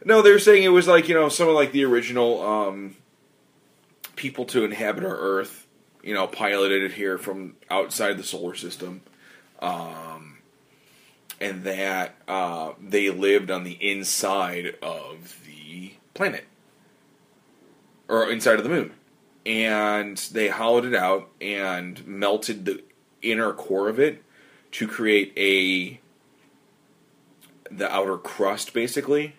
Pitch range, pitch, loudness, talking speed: 95-120 Hz, 100 Hz, -23 LUFS, 135 wpm